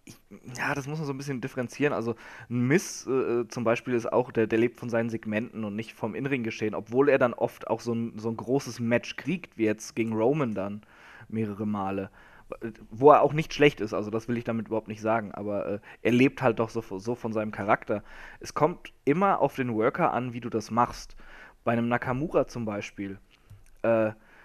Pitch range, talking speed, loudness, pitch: 110-125 Hz, 215 wpm, -28 LUFS, 115 Hz